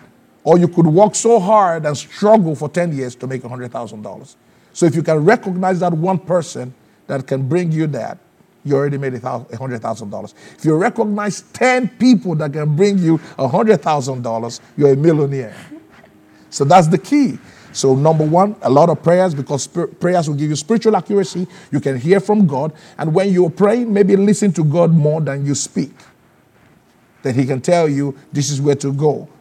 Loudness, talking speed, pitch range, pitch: -16 LUFS, 180 wpm, 140-190 Hz, 165 Hz